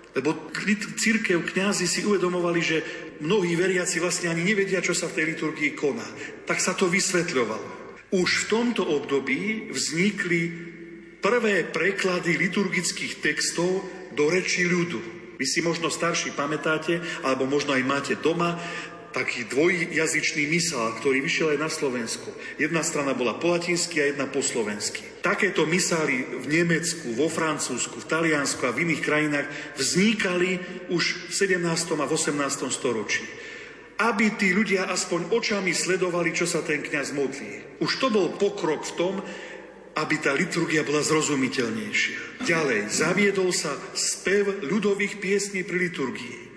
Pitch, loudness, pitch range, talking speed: 175 Hz, -24 LUFS, 155-185 Hz, 140 wpm